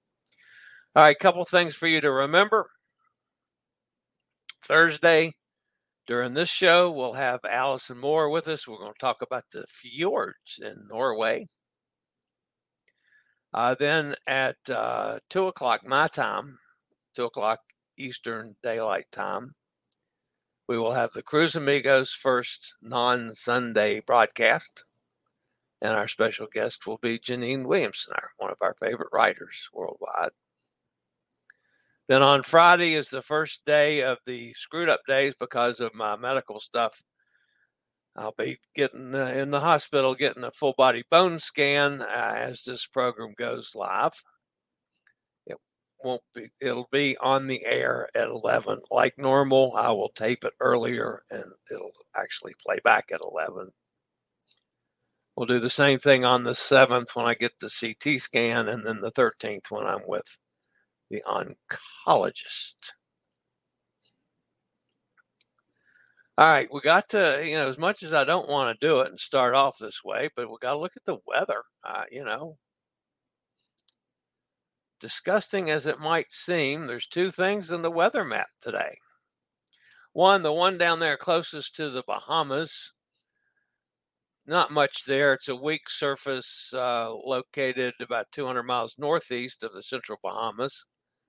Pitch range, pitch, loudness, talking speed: 125-165 Hz, 140 Hz, -25 LUFS, 145 wpm